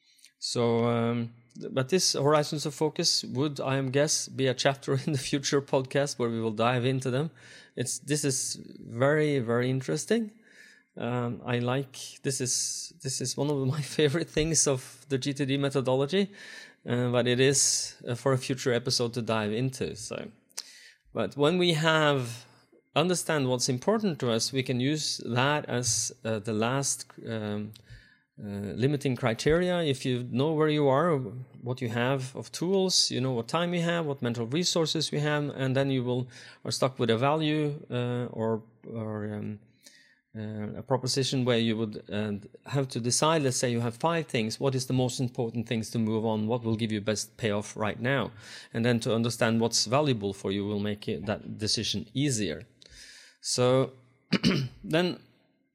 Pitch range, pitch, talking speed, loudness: 115-145 Hz, 130 Hz, 175 wpm, -28 LUFS